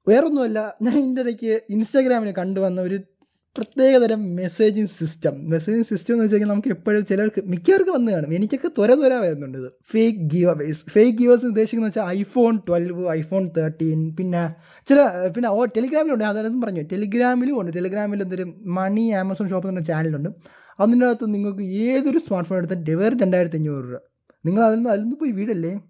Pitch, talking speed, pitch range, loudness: 205 Hz, 140 wpm, 180-235 Hz, -20 LUFS